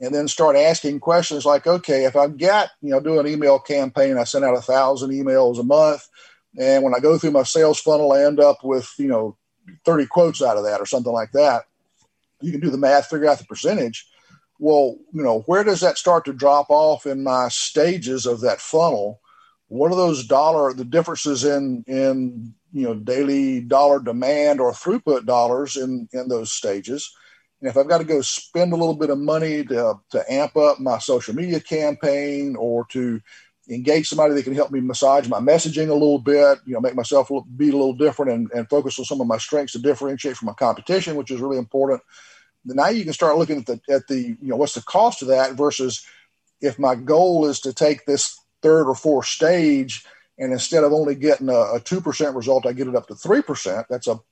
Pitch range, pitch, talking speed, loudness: 130-155 Hz, 140 Hz, 220 wpm, -19 LUFS